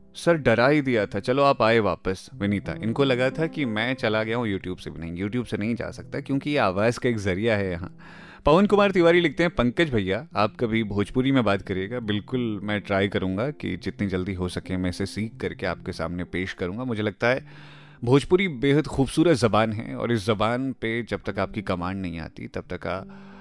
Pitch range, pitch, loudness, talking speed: 95-135 Hz, 110 Hz, -24 LUFS, 220 wpm